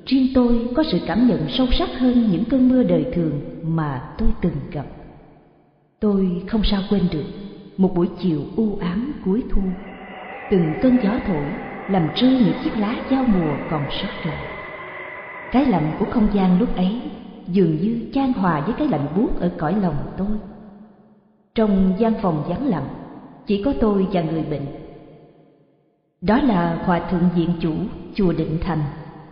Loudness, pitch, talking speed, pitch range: -21 LUFS, 195 Hz, 170 wpm, 175-230 Hz